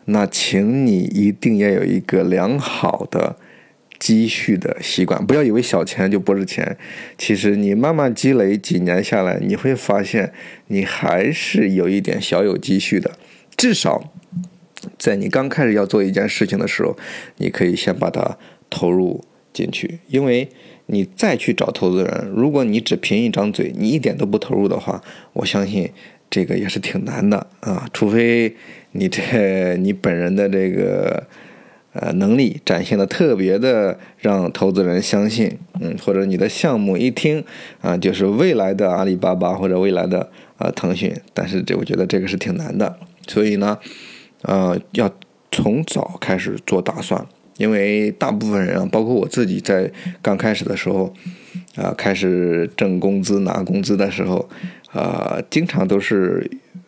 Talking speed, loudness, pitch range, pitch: 245 characters per minute, -18 LUFS, 95-130 Hz, 100 Hz